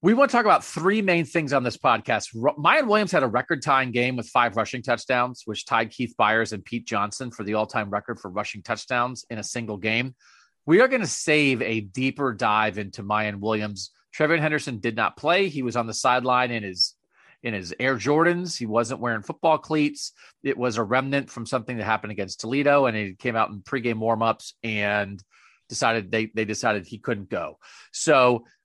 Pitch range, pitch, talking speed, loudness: 110-135 Hz, 120 Hz, 205 wpm, -24 LUFS